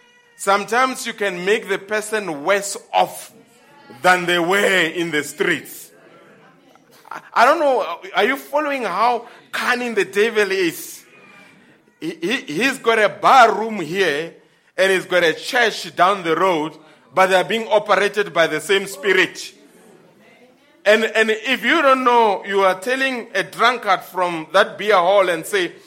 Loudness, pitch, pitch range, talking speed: -18 LUFS, 215 Hz, 190-250 Hz, 150 wpm